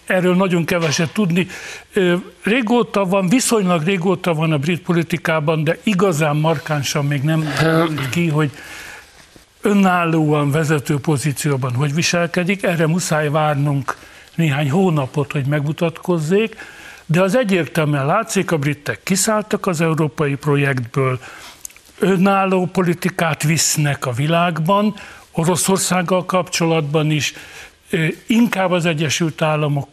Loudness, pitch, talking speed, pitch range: -17 LUFS, 165 Hz, 105 wpm, 150-185 Hz